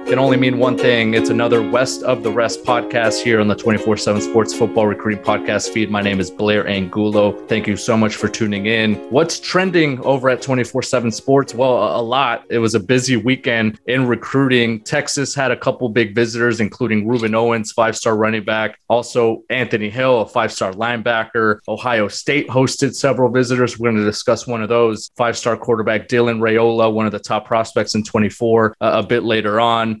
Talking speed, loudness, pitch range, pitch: 200 wpm, -17 LUFS, 110-125 Hz, 115 Hz